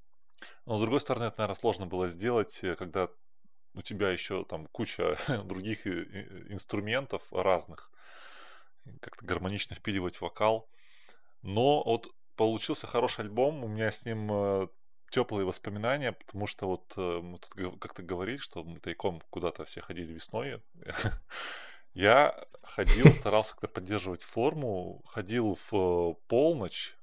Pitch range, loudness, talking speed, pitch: 90-115 Hz, -31 LUFS, 125 wpm, 105 Hz